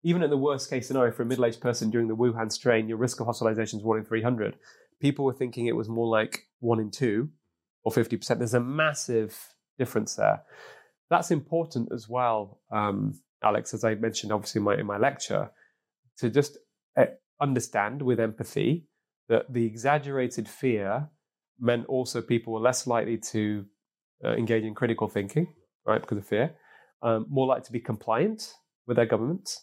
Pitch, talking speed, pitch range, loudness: 120 Hz, 180 wpm, 110-130 Hz, -28 LUFS